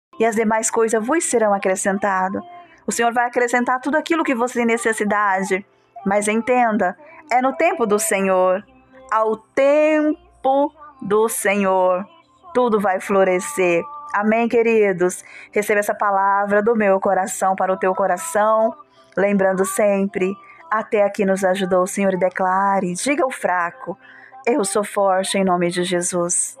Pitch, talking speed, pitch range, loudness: 210 Hz, 140 wpm, 190-240 Hz, -19 LUFS